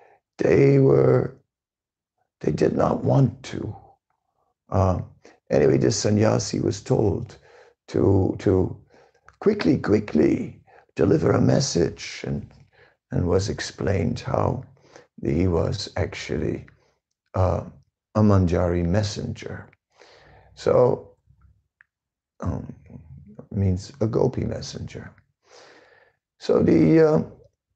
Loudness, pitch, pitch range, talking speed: -22 LUFS, 105 Hz, 90-130 Hz, 90 wpm